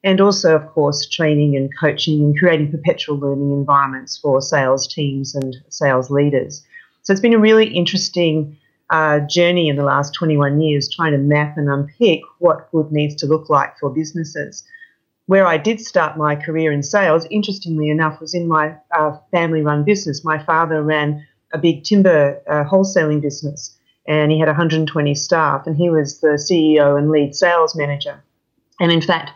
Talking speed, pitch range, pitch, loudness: 180 wpm, 145-170 Hz, 155 Hz, -16 LUFS